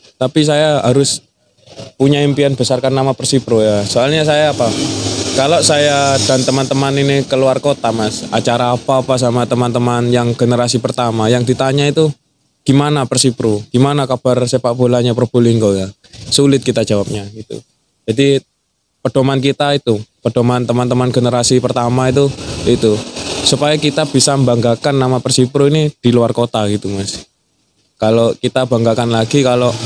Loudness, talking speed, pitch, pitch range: -13 LUFS, 140 wpm, 125 Hz, 120-140 Hz